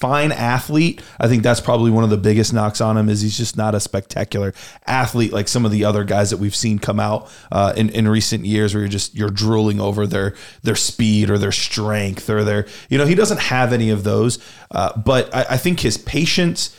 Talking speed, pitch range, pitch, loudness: 230 wpm, 105-120 Hz, 110 Hz, -18 LUFS